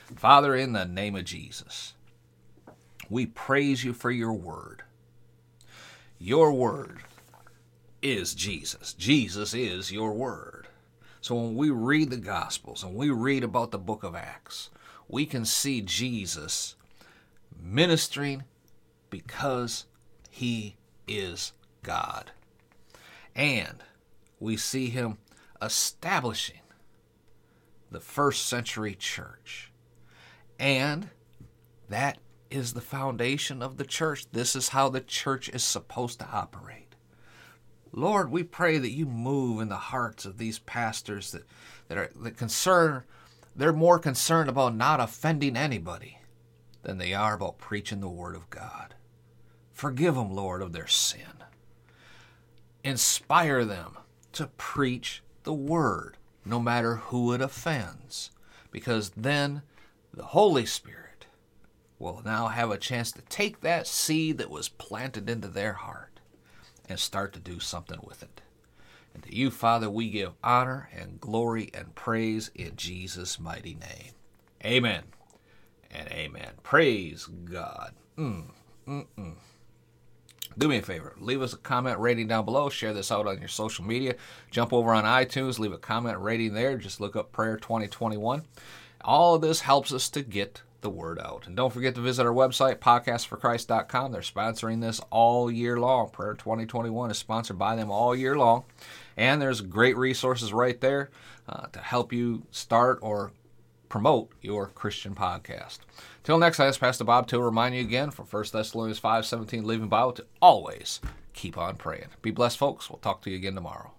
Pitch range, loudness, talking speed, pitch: 110-130 Hz, -28 LUFS, 145 wpm, 115 Hz